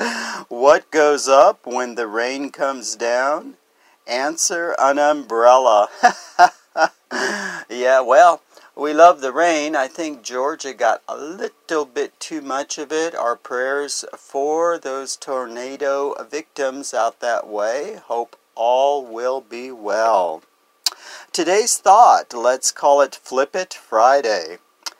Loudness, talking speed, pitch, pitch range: -18 LUFS, 120 wpm, 135 Hz, 125-150 Hz